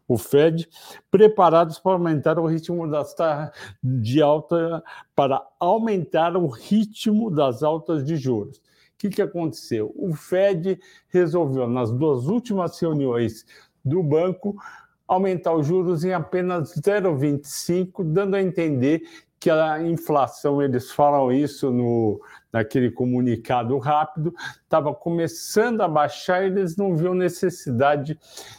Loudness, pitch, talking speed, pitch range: -22 LUFS, 165 Hz, 125 wpm, 145-180 Hz